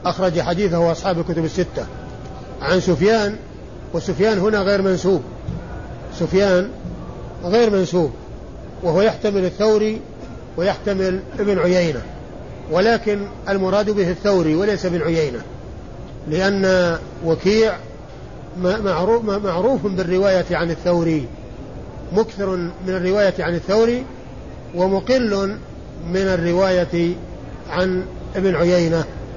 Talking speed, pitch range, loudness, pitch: 90 wpm, 170-200 Hz, -19 LUFS, 185 Hz